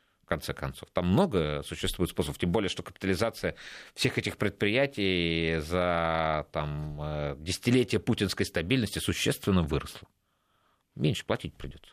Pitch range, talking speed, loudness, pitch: 75-100 Hz, 120 wpm, -29 LUFS, 90 Hz